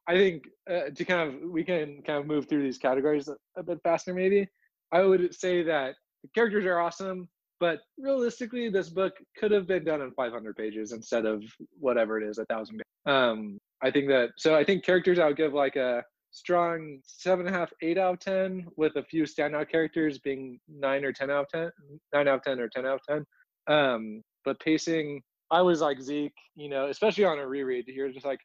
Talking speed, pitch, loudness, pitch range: 220 wpm, 155 Hz, -28 LUFS, 135-180 Hz